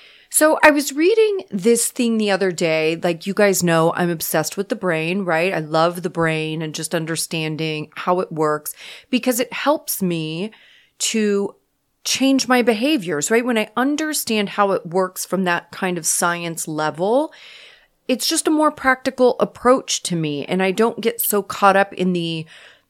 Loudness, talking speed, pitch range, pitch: -19 LUFS, 175 wpm, 165-250 Hz, 195 Hz